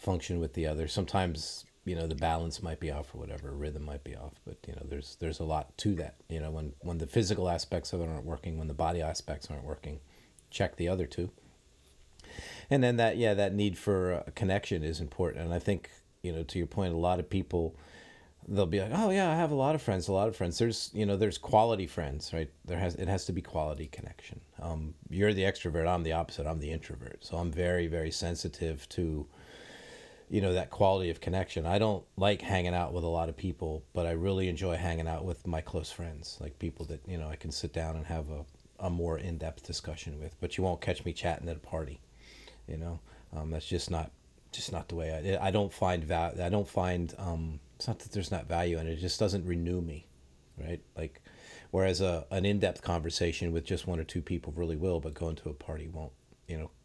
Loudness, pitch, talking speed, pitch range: -34 LUFS, 85 Hz, 235 wpm, 80-95 Hz